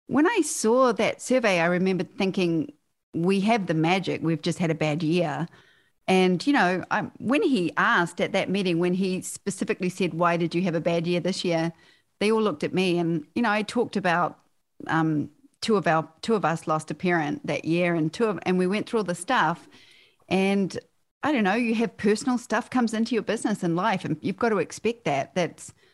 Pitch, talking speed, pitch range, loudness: 180 Hz, 220 wpm, 170-220 Hz, -25 LUFS